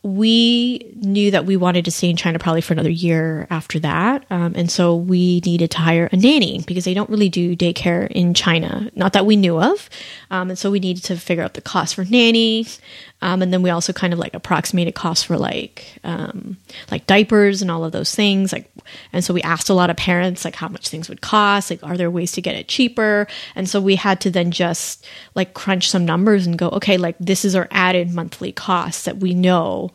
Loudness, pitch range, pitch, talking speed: -17 LUFS, 170-200 Hz, 180 Hz, 230 wpm